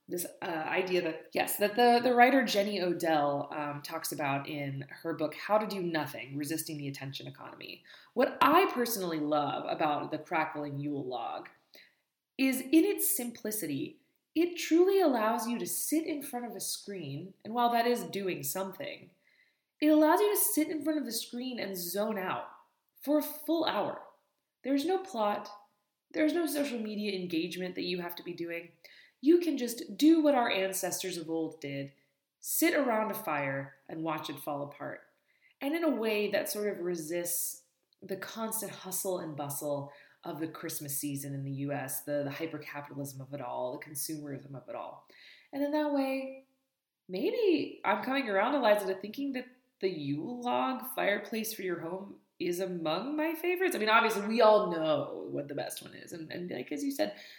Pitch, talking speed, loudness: 200 Hz, 185 wpm, -32 LUFS